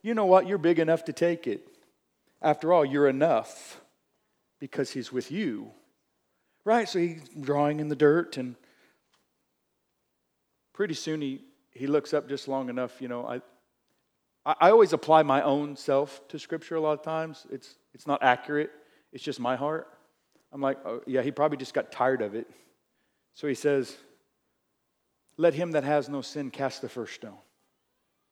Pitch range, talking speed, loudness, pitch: 135-160 Hz, 170 wpm, -27 LUFS, 145 Hz